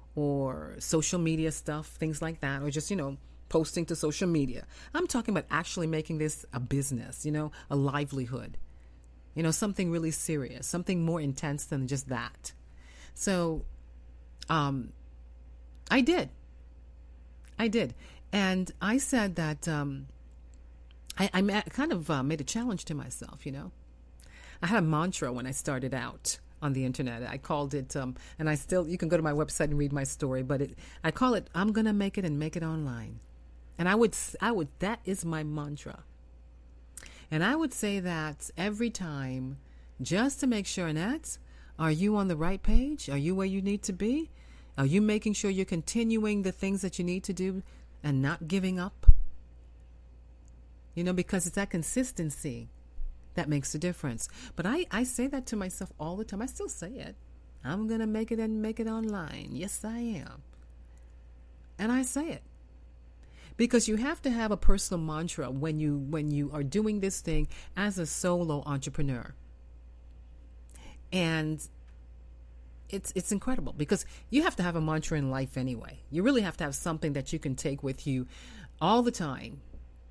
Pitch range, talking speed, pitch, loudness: 125-190 Hz, 180 wpm, 155 Hz, -31 LUFS